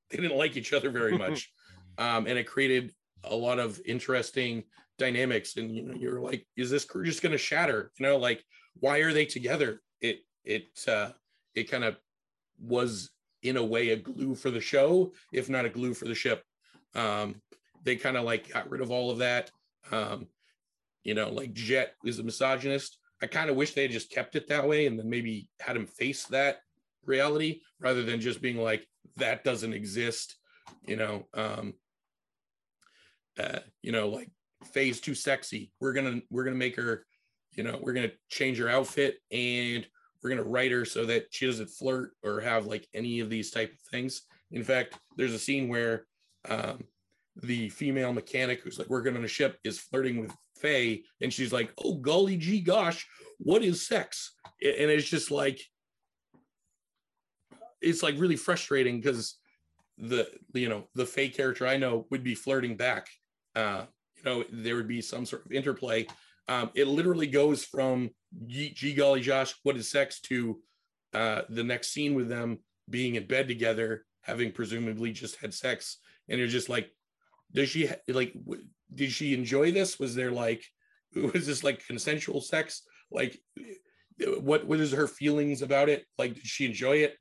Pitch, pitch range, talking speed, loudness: 130 Hz, 115-140 Hz, 185 wpm, -30 LUFS